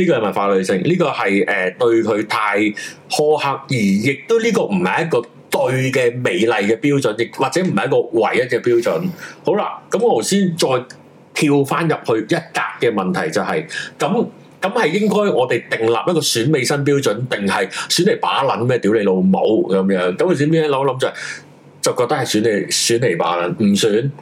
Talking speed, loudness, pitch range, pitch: 280 characters per minute, -17 LUFS, 120-200 Hz, 150 Hz